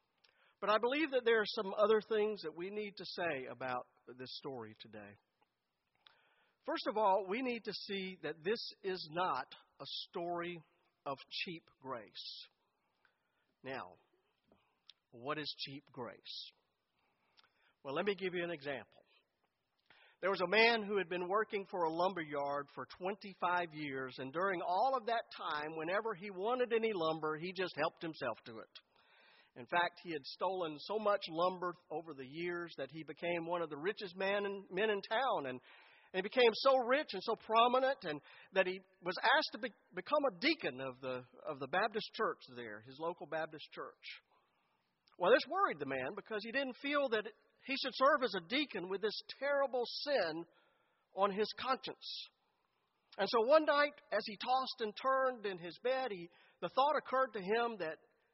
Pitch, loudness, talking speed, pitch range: 190 Hz, -37 LUFS, 175 wpm, 160-230 Hz